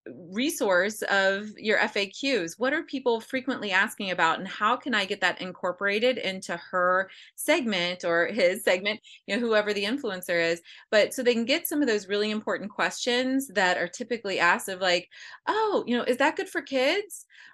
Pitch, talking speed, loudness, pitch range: 210 Hz, 185 wpm, -26 LUFS, 185-260 Hz